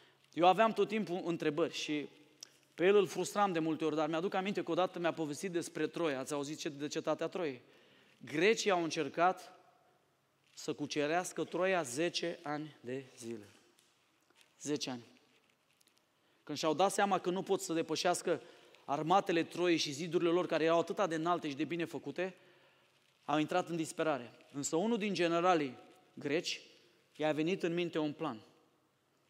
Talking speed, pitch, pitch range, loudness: 160 wpm, 165 Hz, 150-180 Hz, -35 LUFS